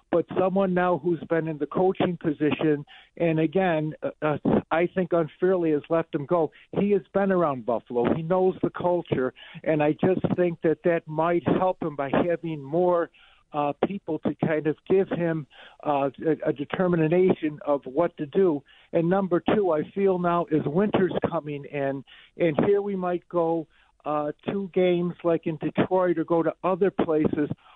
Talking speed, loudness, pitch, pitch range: 175 wpm, -25 LUFS, 165 Hz, 155-180 Hz